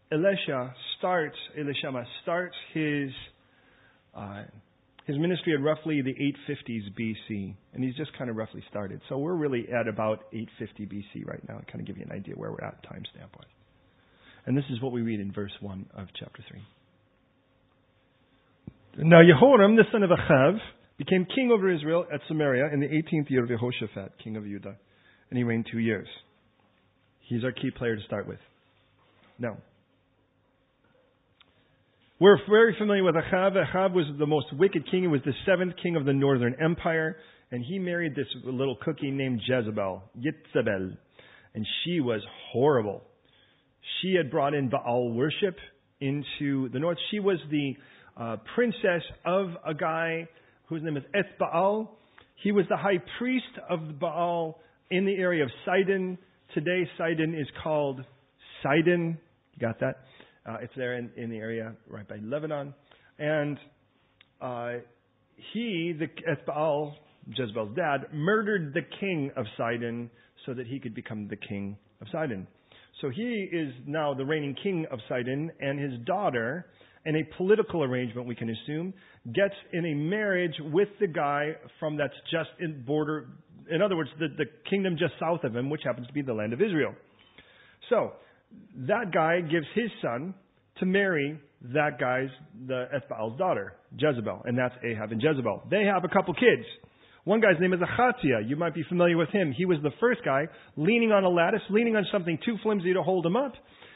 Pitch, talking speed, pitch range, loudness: 150 Hz, 170 wpm, 125-175 Hz, -28 LUFS